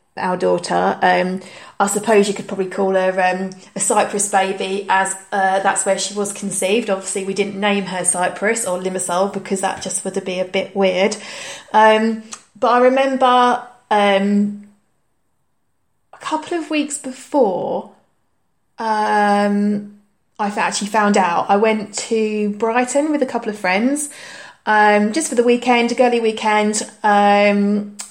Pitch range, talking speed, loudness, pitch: 195-225 Hz, 155 wpm, -17 LUFS, 205 Hz